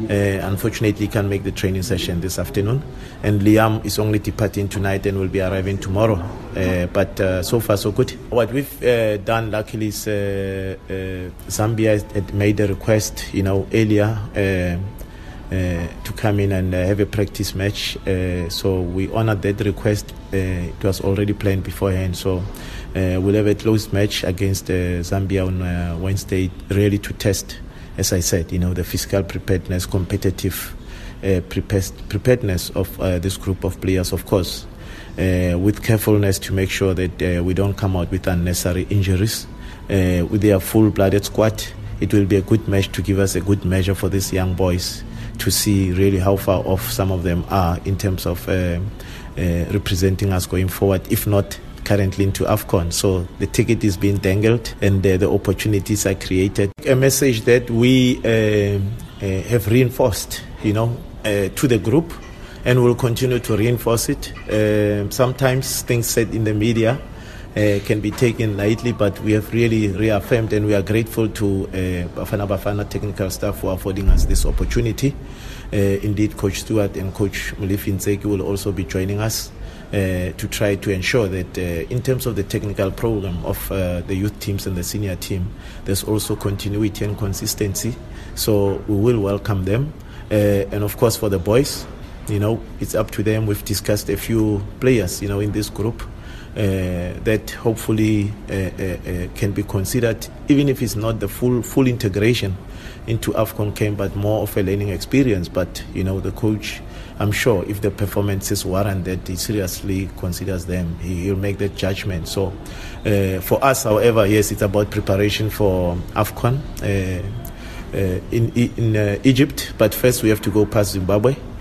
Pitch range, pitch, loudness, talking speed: 95-110 Hz, 100 Hz, -20 LUFS, 180 wpm